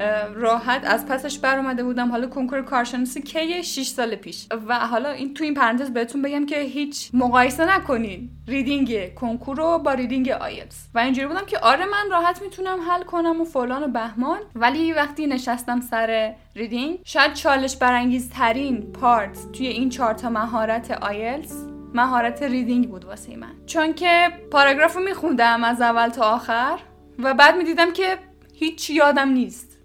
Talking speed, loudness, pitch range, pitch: 170 wpm, -21 LUFS, 235-300 Hz, 260 Hz